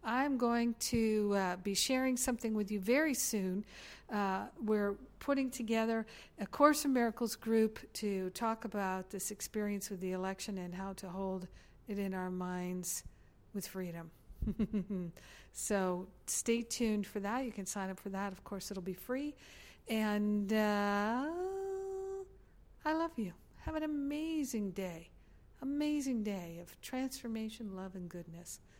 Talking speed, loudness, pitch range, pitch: 145 wpm, -37 LUFS, 190-245 Hz, 210 Hz